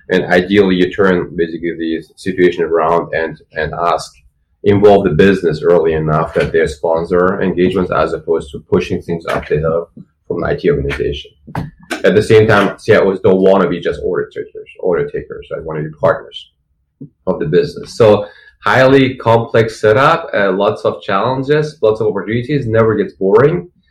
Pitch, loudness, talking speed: 100 Hz, -13 LUFS, 170 wpm